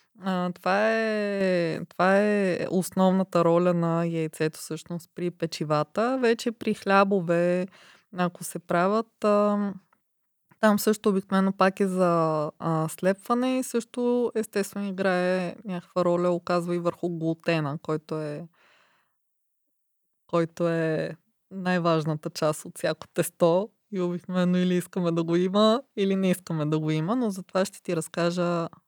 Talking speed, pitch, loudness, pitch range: 125 wpm, 180 Hz, -26 LUFS, 170-200 Hz